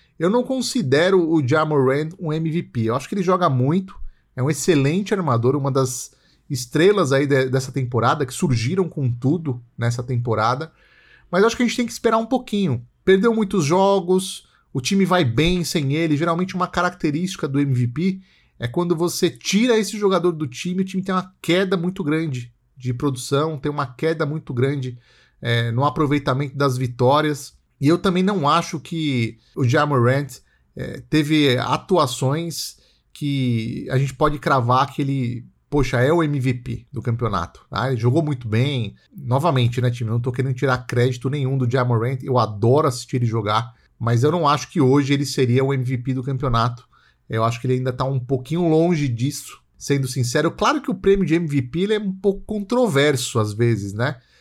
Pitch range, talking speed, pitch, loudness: 125-175 Hz, 185 wpm, 140 Hz, -20 LUFS